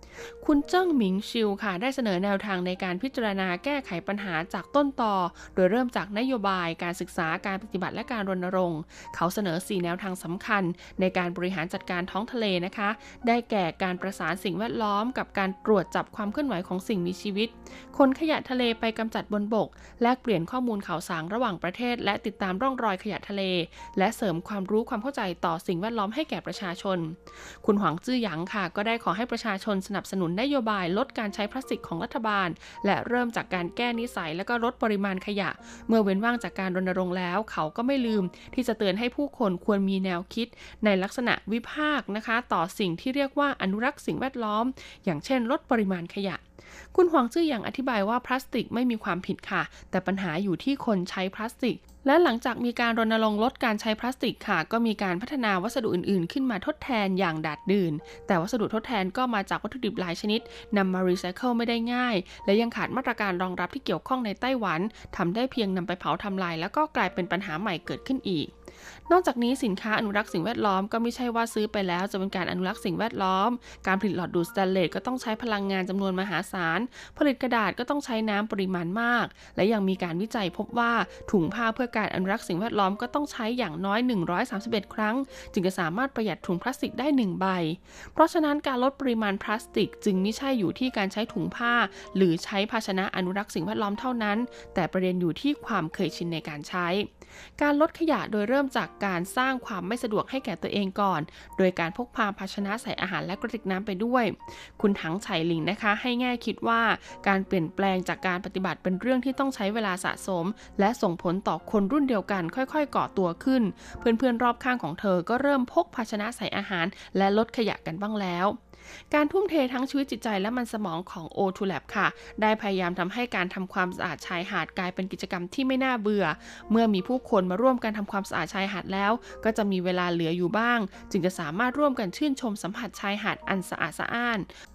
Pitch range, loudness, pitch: 185-240 Hz, -28 LUFS, 205 Hz